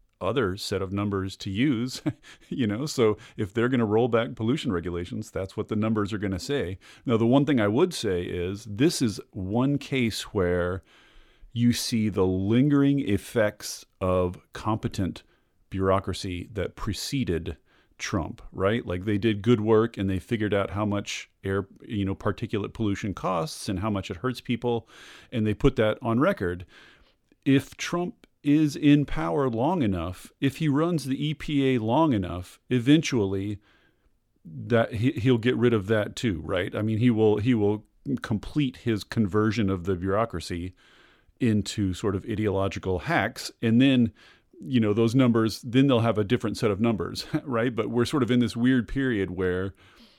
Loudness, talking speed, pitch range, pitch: -26 LUFS, 170 wpm, 100-125 Hz, 110 Hz